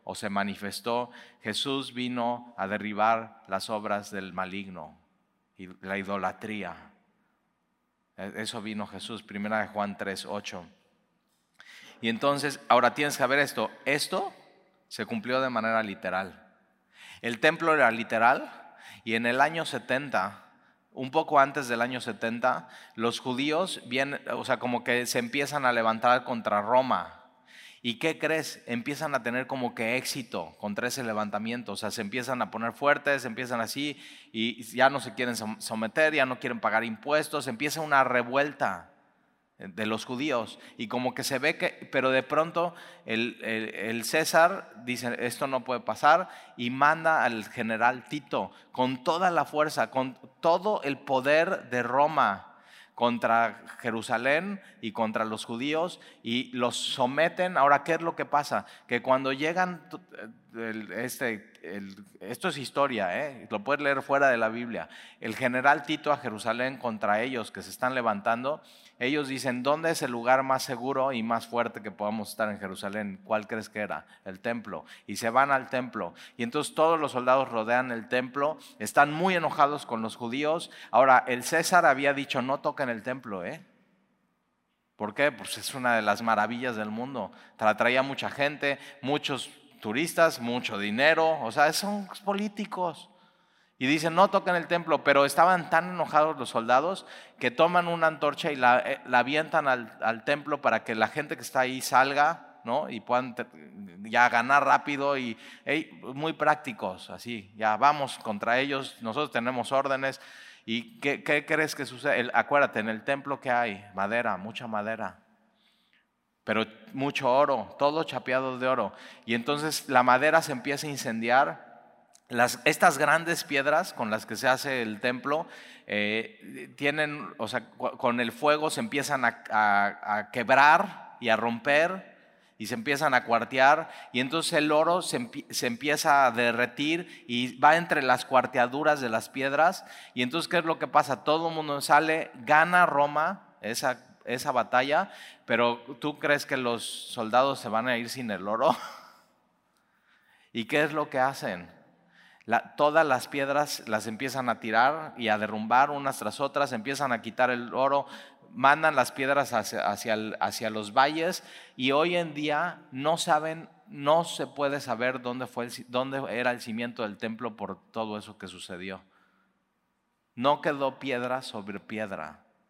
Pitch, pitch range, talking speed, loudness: 130 Hz, 115-150 Hz, 165 wpm, -27 LUFS